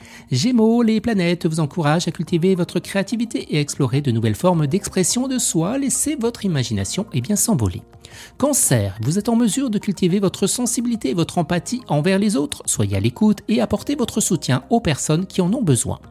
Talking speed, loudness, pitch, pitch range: 195 wpm, -19 LUFS, 185 Hz, 145-225 Hz